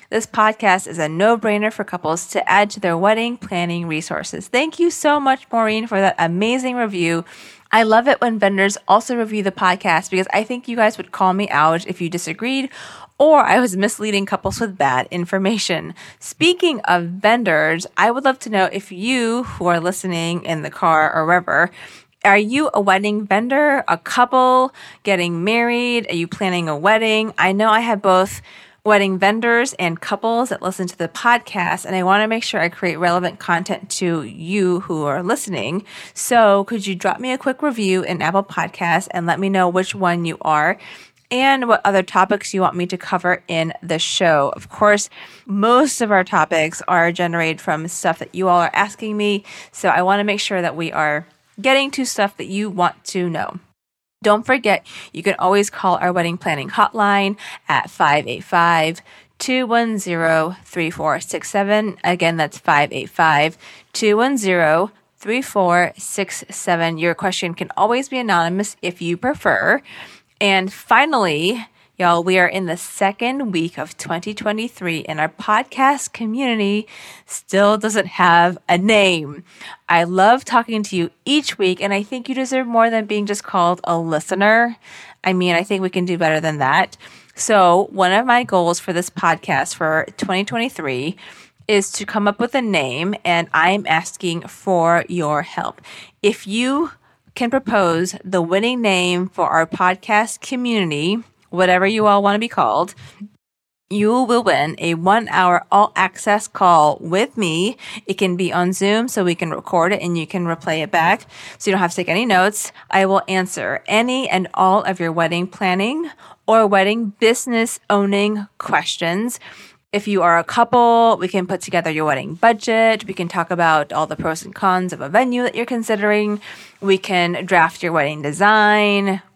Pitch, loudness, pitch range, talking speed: 195 Hz, -17 LUFS, 175-220 Hz, 175 wpm